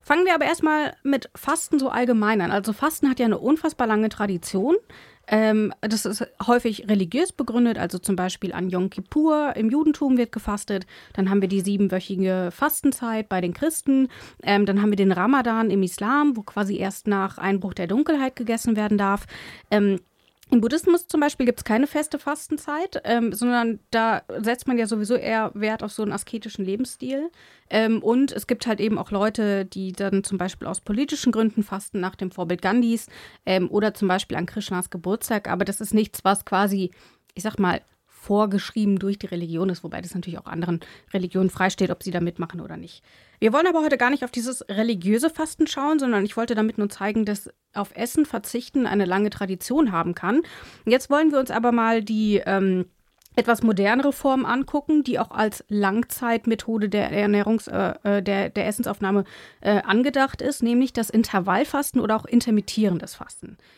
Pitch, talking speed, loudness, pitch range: 220 Hz, 185 wpm, -23 LUFS, 195-250 Hz